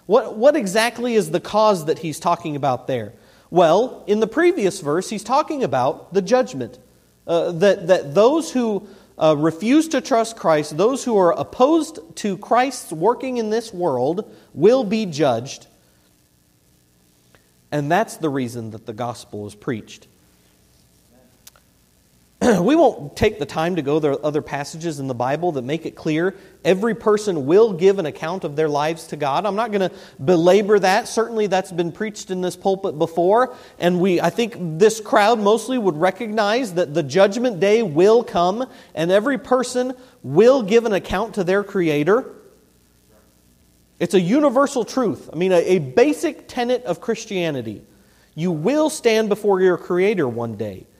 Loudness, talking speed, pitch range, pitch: -19 LUFS, 165 wpm, 150-225 Hz, 185 Hz